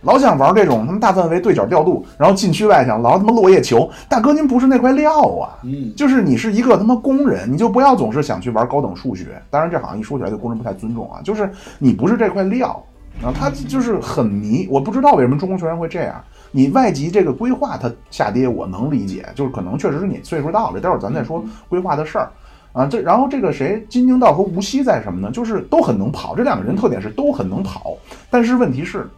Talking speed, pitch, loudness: 370 characters per minute, 210 Hz, -16 LUFS